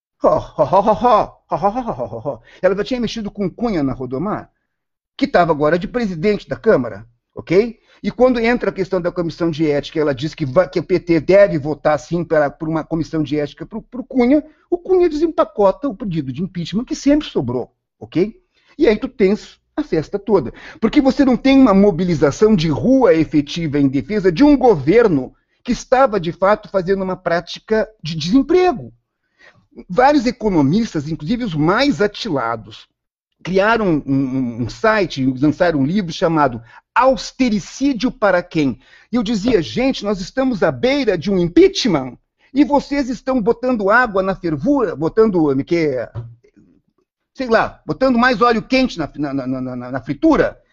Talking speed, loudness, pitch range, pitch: 155 wpm, -17 LUFS, 155-250 Hz, 195 Hz